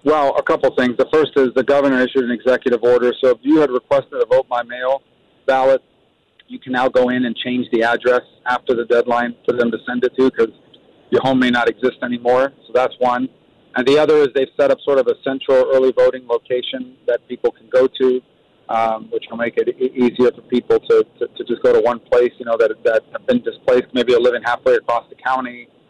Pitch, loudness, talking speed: 130 Hz, -17 LUFS, 230 wpm